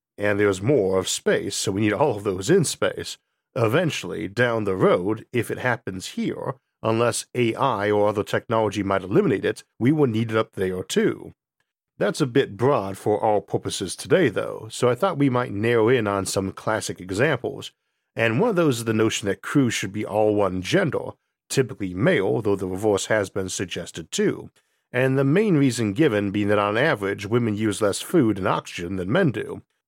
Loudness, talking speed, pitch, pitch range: -23 LUFS, 195 wpm, 110 Hz, 100-125 Hz